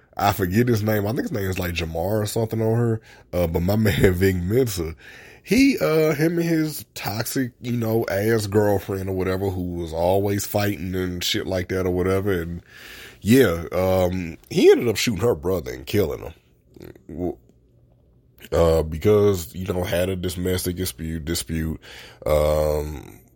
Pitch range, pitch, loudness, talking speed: 90-110 Hz, 95 Hz, -22 LUFS, 165 wpm